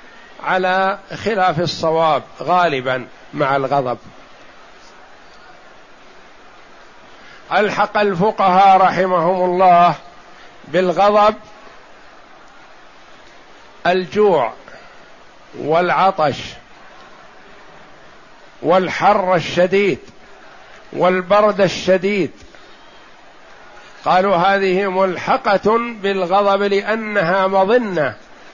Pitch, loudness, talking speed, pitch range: 185 Hz, -16 LUFS, 50 wpm, 175-200 Hz